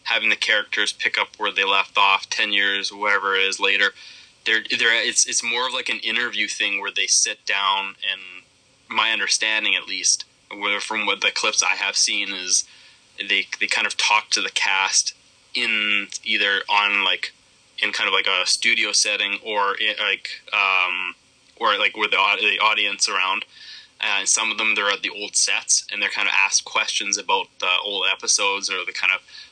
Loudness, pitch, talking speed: -19 LUFS, 105 Hz, 190 wpm